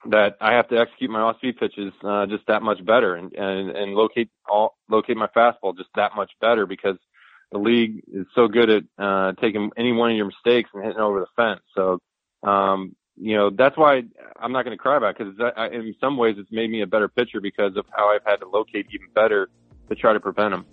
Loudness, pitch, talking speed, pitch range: -21 LUFS, 105 Hz, 235 wpm, 100-115 Hz